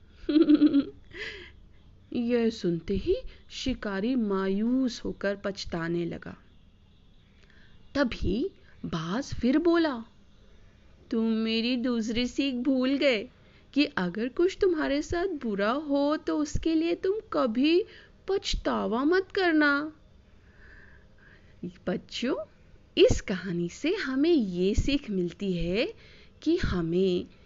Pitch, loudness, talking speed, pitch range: 255 Hz, -28 LUFS, 95 wpm, 195-310 Hz